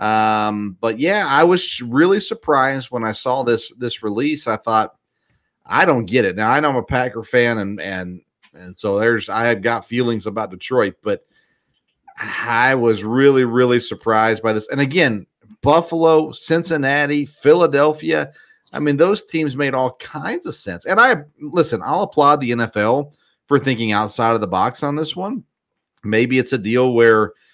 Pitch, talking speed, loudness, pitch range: 125 Hz, 175 wpm, -17 LUFS, 110-145 Hz